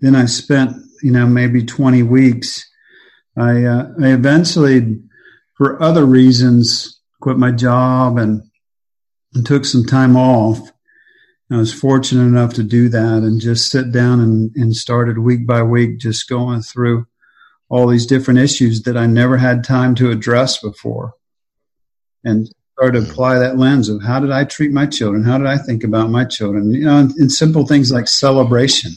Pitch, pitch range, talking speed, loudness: 125 Hz, 115-130 Hz, 175 wpm, -13 LUFS